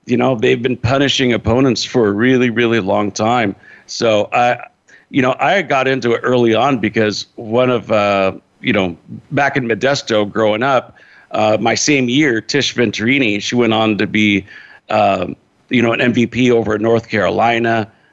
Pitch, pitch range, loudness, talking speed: 115 Hz, 110-125 Hz, -15 LUFS, 175 wpm